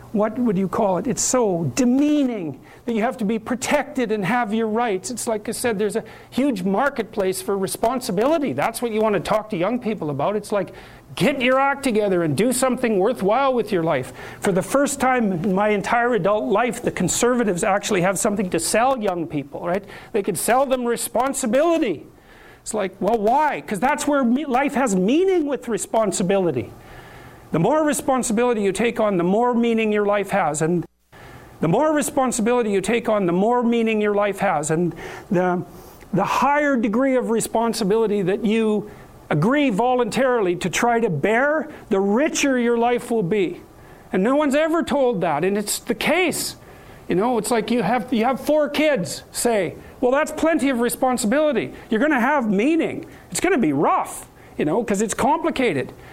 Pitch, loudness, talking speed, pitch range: 230 Hz, -20 LUFS, 185 wpm, 200-260 Hz